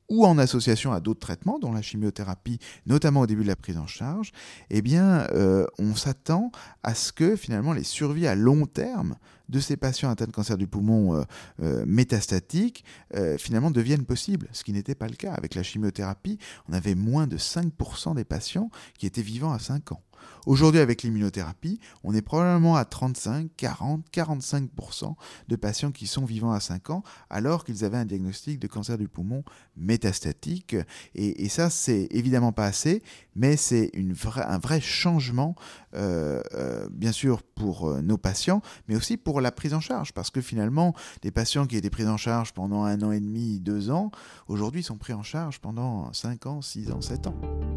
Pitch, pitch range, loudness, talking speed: 115 Hz, 105-150 Hz, -27 LUFS, 190 wpm